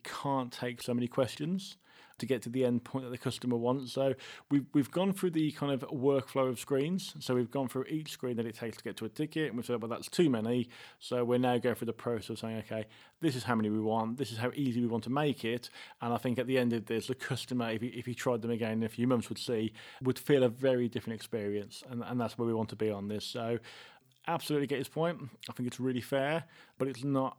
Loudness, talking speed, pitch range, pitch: -34 LUFS, 270 wpm, 115-135 Hz, 125 Hz